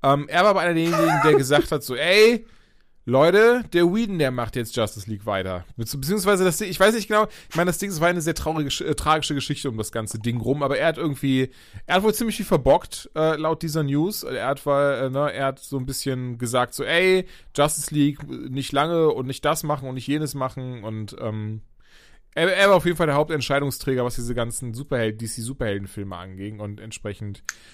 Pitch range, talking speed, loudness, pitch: 120-165 Hz, 220 wpm, -22 LUFS, 140 Hz